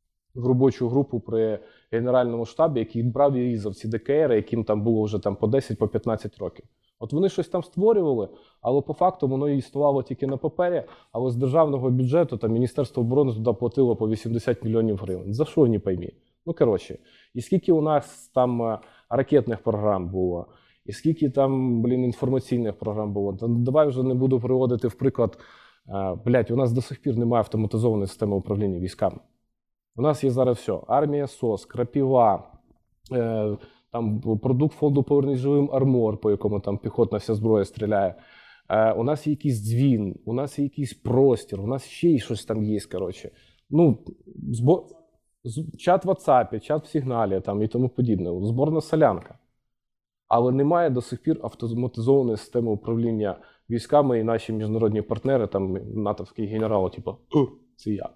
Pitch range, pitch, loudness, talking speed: 110-135 Hz, 120 Hz, -24 LUFS, 165 wpm